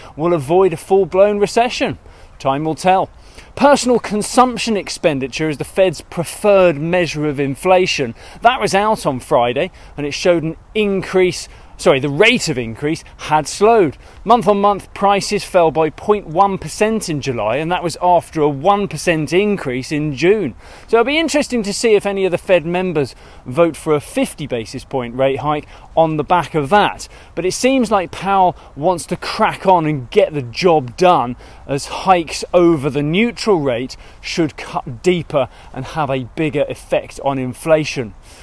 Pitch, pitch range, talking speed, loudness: 170 Hz, 145-200 Hz, 170 wpm, -16 LUFS